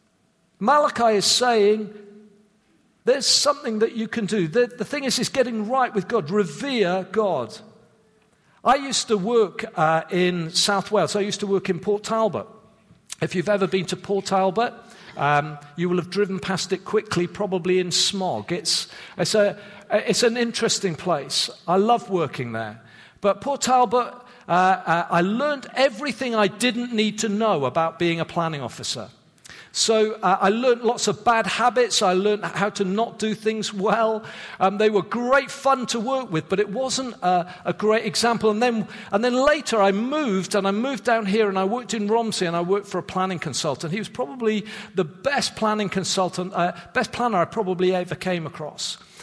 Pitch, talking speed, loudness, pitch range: 210 Hz, 185 wpm, -22 LUFS, 185-230 Hz